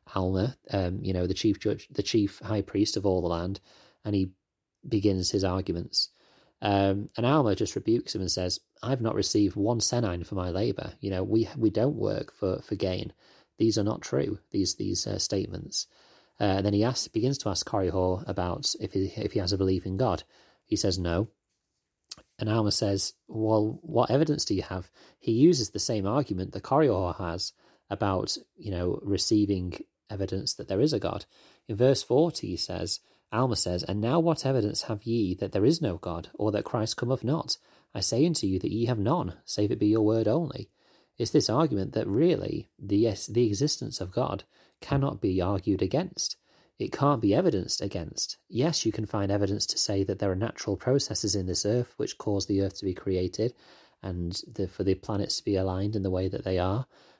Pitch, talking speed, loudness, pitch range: 100 Hz, 205 wpm, -28 LUFS, 95-115 Hz